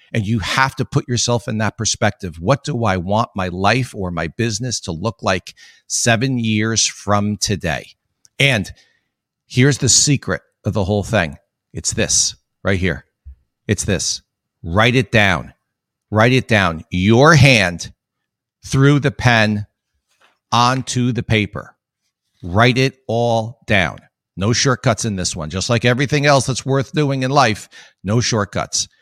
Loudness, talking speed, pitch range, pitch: -17 LUFS, 150 wpm, 100-130 Hz, 110 Hz